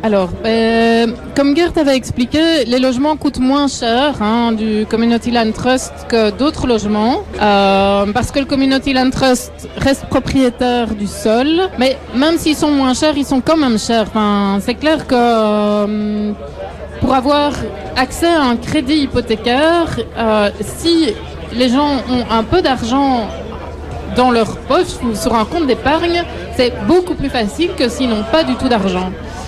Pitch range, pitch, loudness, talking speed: 225-285 Hz, 250 Hz, -14 LUFS, 165 wpm